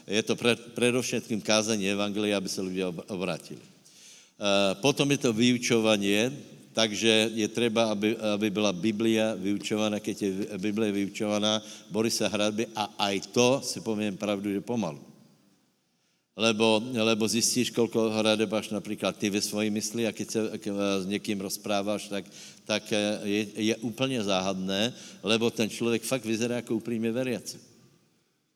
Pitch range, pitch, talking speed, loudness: 105-115 Hz, 110 Hz, 150 wpm, -28 LUFS